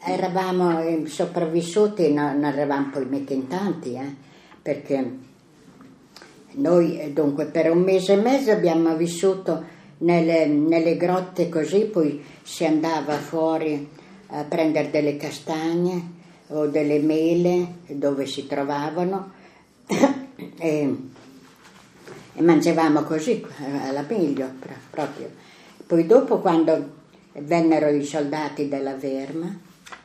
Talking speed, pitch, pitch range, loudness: 100 wpm, 160 Hz, 145-175 Hz, -22 LUFS